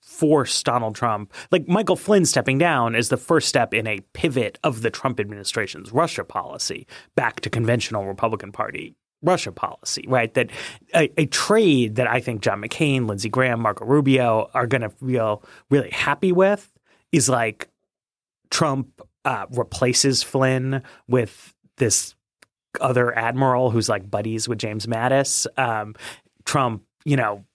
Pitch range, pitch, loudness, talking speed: 110-135 Hz, 125 Hz, -21 LUFS, 150 wpm